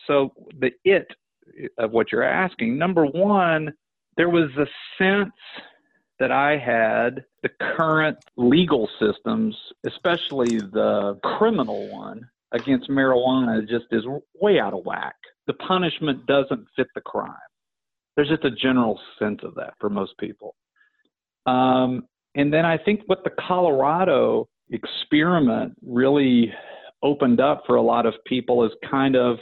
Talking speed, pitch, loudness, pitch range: 140 wpm, 145 Hz, -22 LUFS, 125-185 Hz